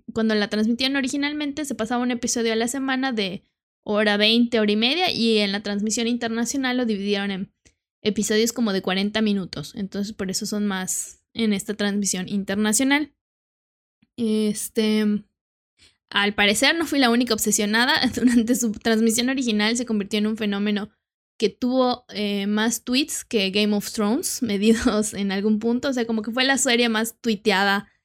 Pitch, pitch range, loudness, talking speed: 220 Hz, 205-245 Hz, -22 LUFS, 165 wpm